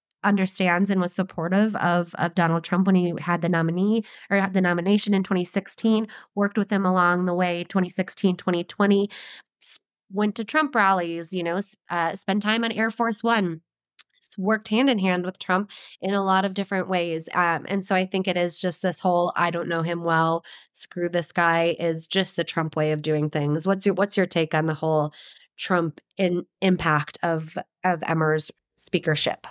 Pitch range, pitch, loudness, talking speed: 170-200 Hz, 180 Hz, -24 LUFS, 190 wpm